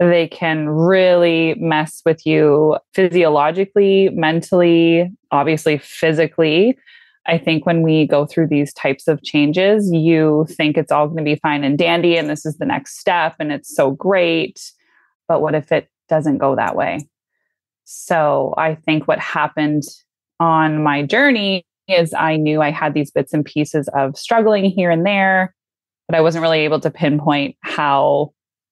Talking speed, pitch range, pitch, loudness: 165 wpm, 150-170 Hz, 160 Hz, -16 LUFS